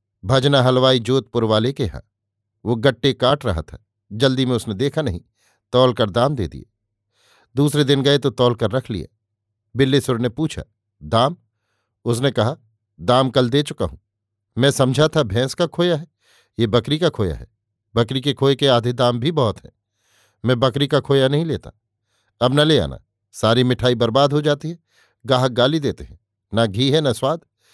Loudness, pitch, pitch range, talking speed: -19 LUFS, 125 Hz, 105-140 Hz, 185 wpm